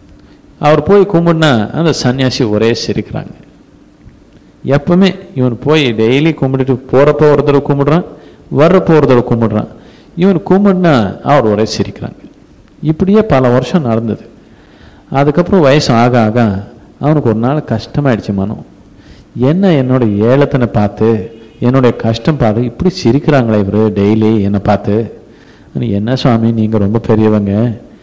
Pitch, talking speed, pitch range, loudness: 125 Hz, 110 wpm, 110-150 Hz, -11 LUFS